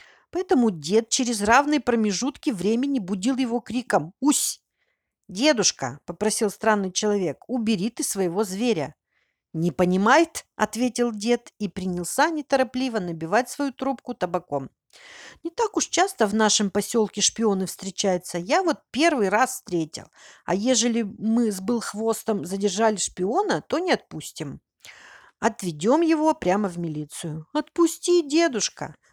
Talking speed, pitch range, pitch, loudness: 125 wpm, 195-270 Hz, 220 Hz, -23 LUFS